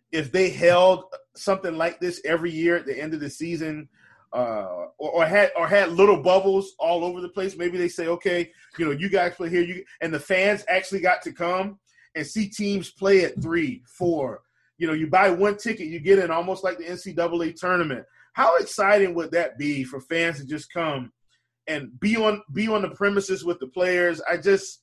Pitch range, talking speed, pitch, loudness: 170-195 Hz, 210 wpm, 180 Hz, -23 LUFS